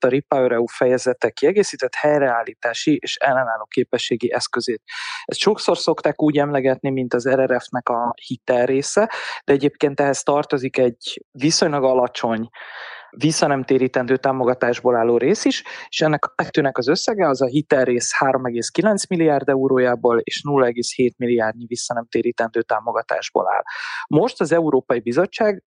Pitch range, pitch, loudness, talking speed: 125-155 Hz, 135 Hz, -19 LUFS, 125 wpm